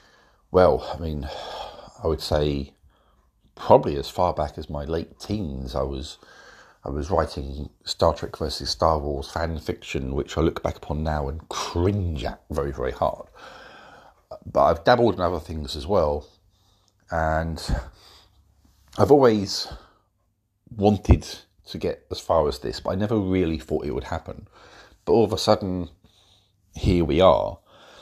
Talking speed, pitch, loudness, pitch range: 155 wpm, 80 Hz, -24 LUFS, 75-95 Hz